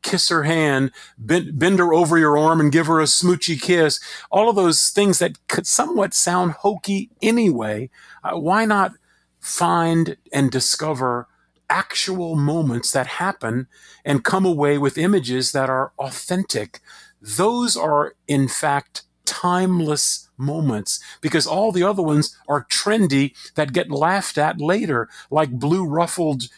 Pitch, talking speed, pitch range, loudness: 160 Hz, 140 wpm, 140-180 Hz, -19 LUFS